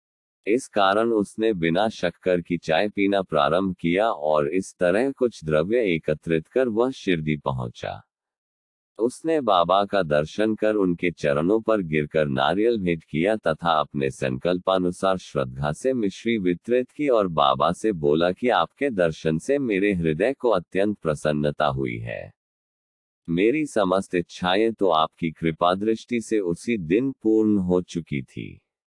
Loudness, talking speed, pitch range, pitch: -23 LUFS, 140 wpm, 80-110 Hz, 90 Hz